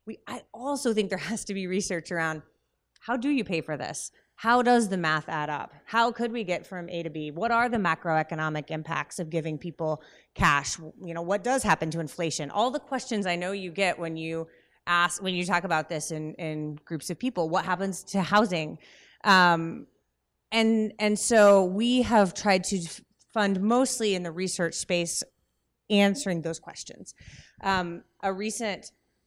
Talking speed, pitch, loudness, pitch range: 185 wpm, 185 Hz, -27 LUFS, 165-215 Hz